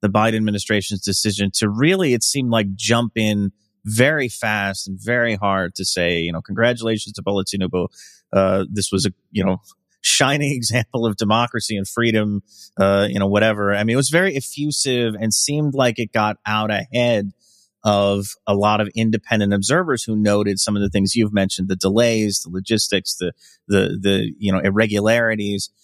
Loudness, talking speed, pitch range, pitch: -19 LUFS, 175 wpm, 100-115 Hz, 105 Hz